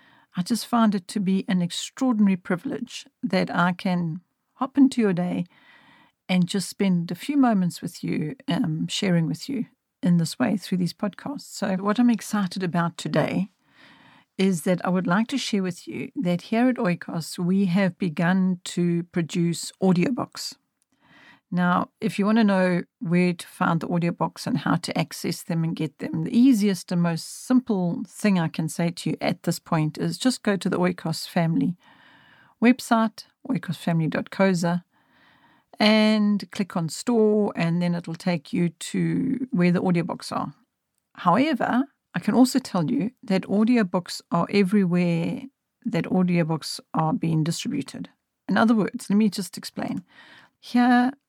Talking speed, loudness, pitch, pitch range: 160 wpm, -24 LUFS, 190 Hz, 175-225 Hz